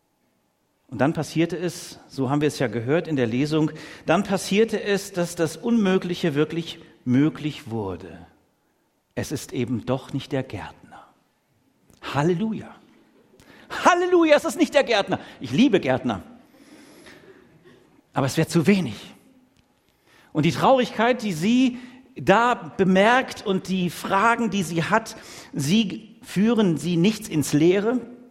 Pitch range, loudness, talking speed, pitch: 150-230 Hz, -22 LUFS, 135 wpm, 180 Hz